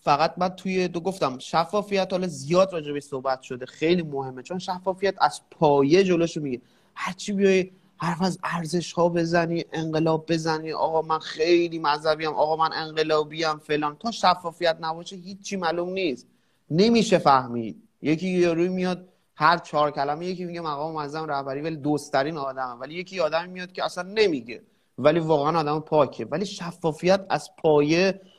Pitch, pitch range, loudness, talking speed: 165 Hz, 150-180 Hz, -24 LUFS, 165 wpm